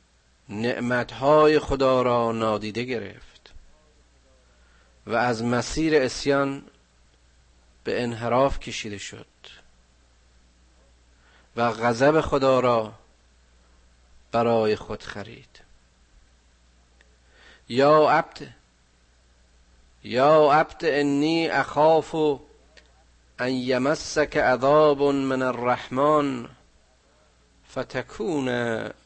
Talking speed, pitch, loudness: 70 wpm, 110 Hz, -23 LUFS